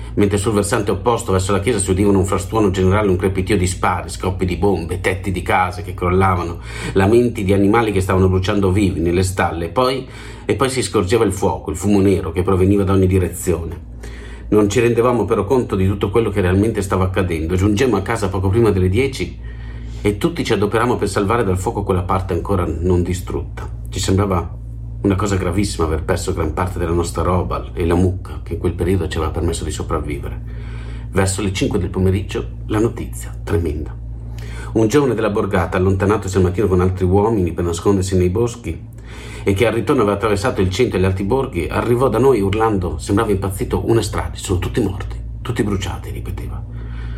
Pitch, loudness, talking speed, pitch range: 95 Hz, -18 LUFS, 195 wpm, 90-110 Hz